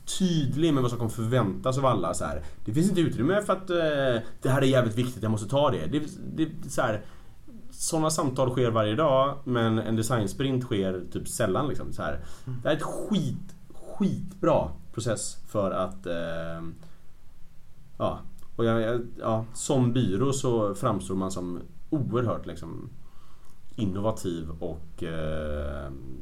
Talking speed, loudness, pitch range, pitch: 155 wpm, -28 LUFS, 95-145 Hz, 120 Hz